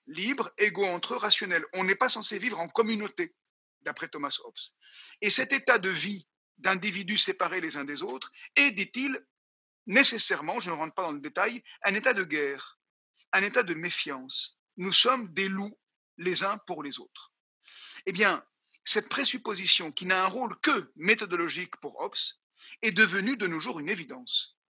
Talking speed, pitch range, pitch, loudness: 175 wpm, 185-255 Hz, 205 Hz, -26 LUFS